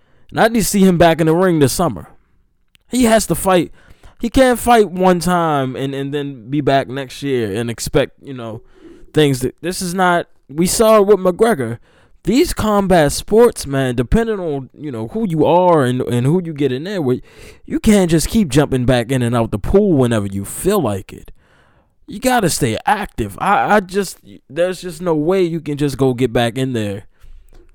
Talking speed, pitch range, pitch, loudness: 205 wpm, 130-190 Hz, 160 Hz, -16 LUFS